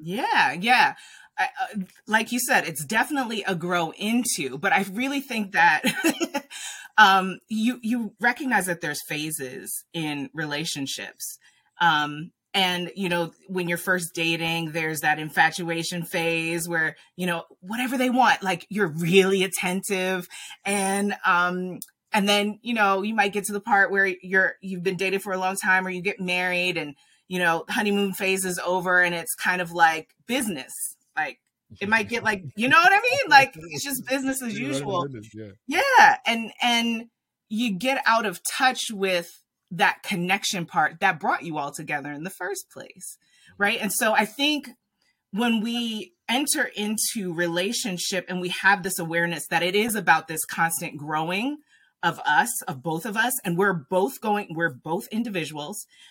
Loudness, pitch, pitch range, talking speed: -23 LUFS, 190 Hz, 170-225 Hz, 170 wpm